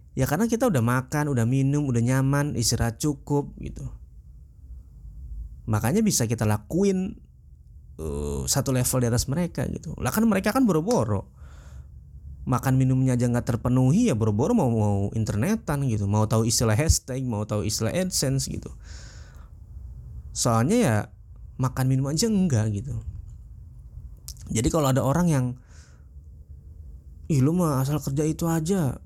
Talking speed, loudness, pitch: 140 wpm, -24 LUFS, 115 Hz